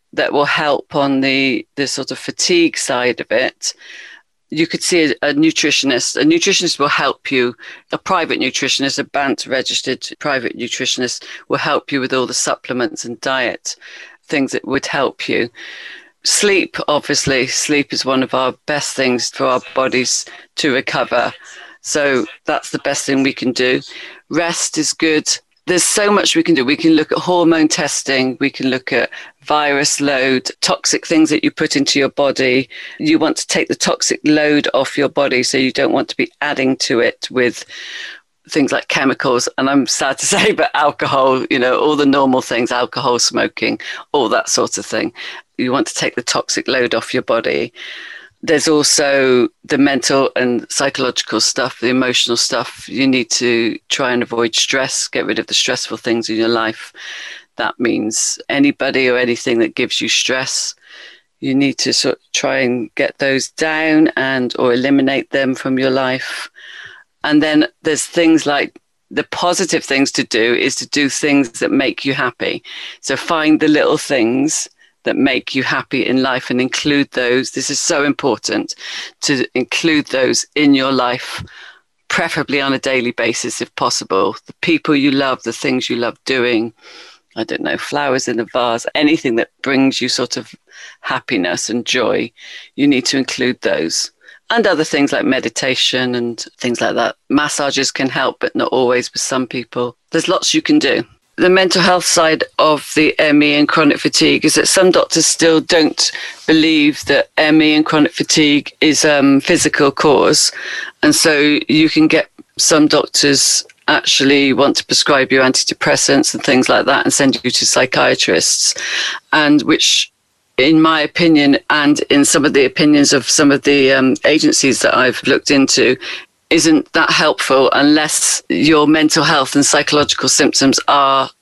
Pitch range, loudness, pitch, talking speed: 130-155 Hz, -14 LUFS, 140 Hz, 175 wpm